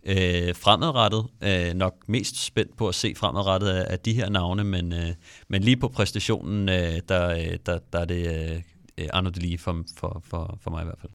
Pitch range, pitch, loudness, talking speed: 85-105 Hz, 95 Hz, -25 LUFS, 205 wpm